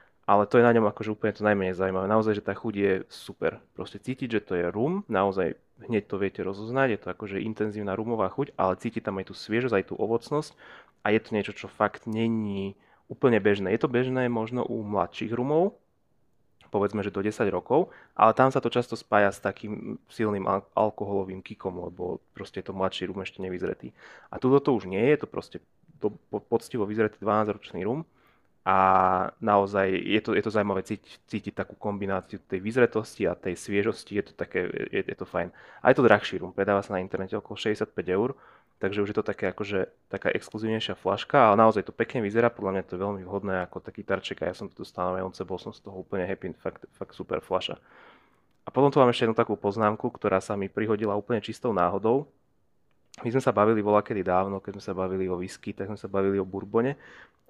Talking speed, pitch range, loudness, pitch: 210 wpm, 95-110 Hz, -27 LUFS, 105 Hz